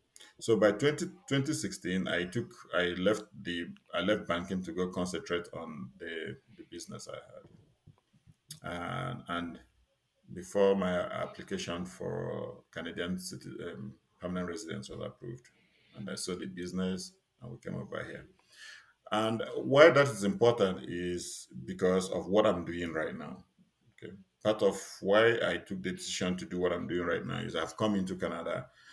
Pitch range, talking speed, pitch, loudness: 85-100 Hz, 160 wpm, 90 Hz, -32 LUFS